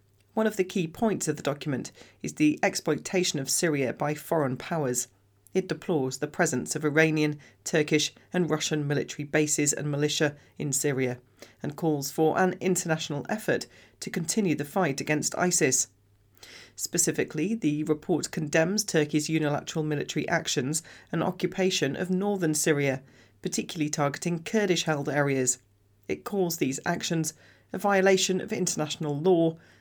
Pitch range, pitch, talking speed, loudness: 145-175 Hz, 155 Hz, 140 wpm, -27 LUFS